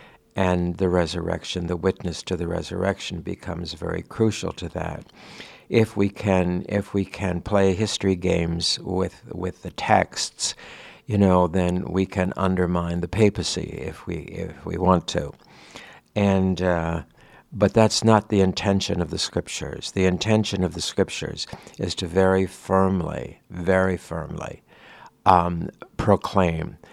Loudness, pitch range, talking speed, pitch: -23 LUFS, 85-100 Hz, 140 wpm, 95 Hz